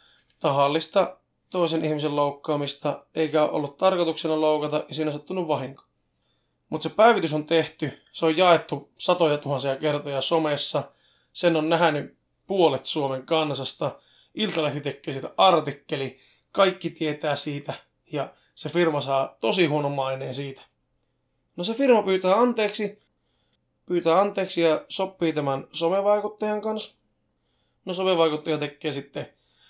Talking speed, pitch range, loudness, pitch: 125 wpm, 140-175 Hz, -24 LUFS, 155 Hz